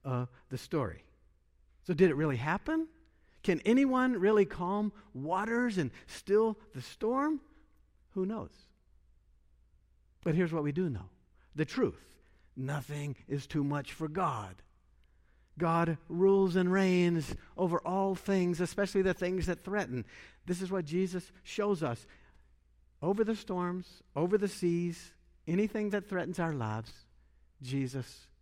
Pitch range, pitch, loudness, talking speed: 125-195 Hz, 170 Hz, -33 LUFS, 135 wpm